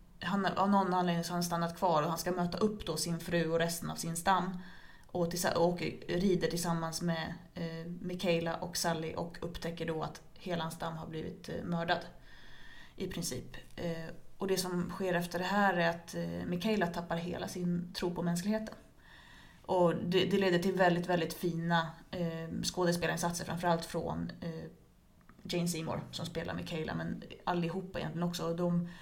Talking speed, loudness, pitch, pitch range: 180 wpm, -34 LUFS, 175 Hz, 165-180 Hz